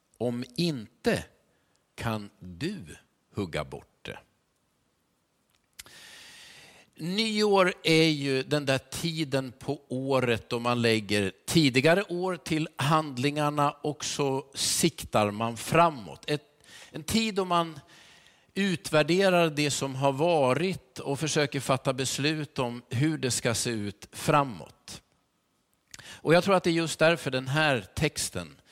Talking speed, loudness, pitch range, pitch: 125 wpm, -27 LUFS, 125-165 Hz, 145 Hz